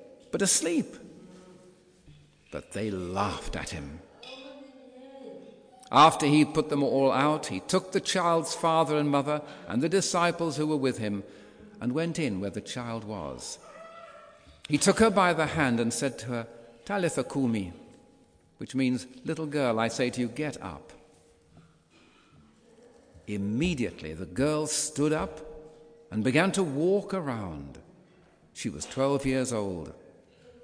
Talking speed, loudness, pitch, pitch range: 140 wpm, -28 LUFS, 150 Hz, 115-180 Hz